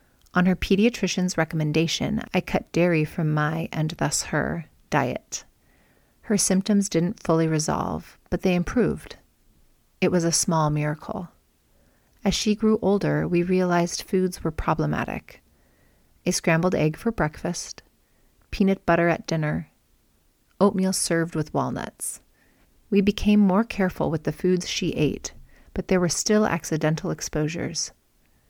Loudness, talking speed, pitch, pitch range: -24 LUFS, 135 wpm, 180 Hz, 160-195 Hz